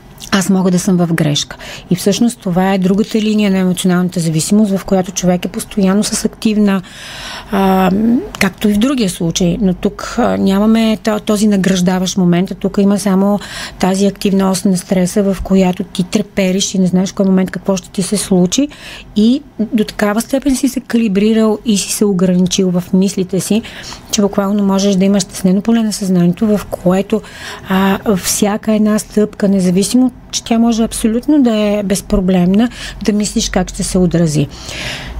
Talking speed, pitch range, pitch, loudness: 175 wpm, 190-215 Hz, 200 Hz, -13 LUFS